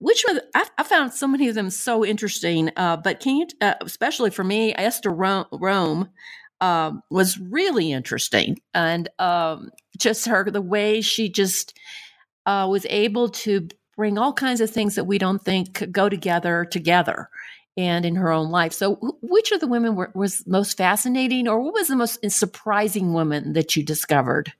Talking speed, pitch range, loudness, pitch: 190 wpm, 180-225 Hz, -21 LUFS, 200 Hz